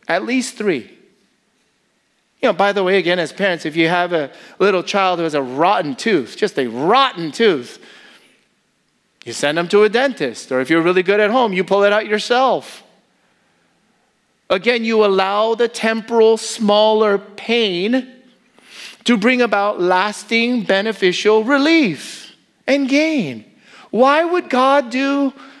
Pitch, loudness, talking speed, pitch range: 215 Hz, -16 LUFS, 150 wpm, 190-250 Hz